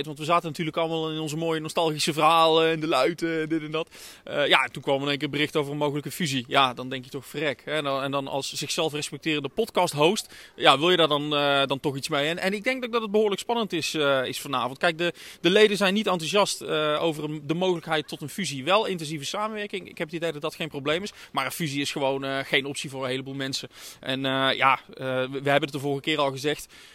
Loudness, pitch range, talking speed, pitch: -25 LUFS, 140-170 Hz, 265 wpm, 155 Hz